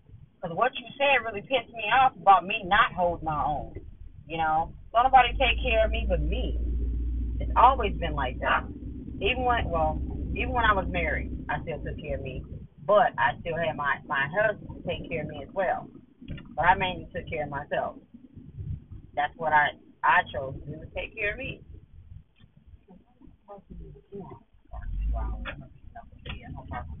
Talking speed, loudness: 165 wpm, -26 LUFS